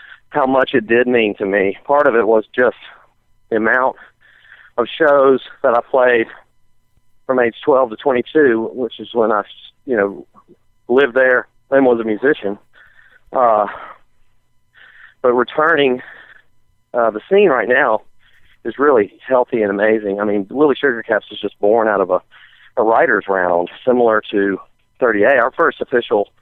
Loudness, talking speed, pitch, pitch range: -15 LUFS, 155 wpm, 115 Hz, 105-125 Hz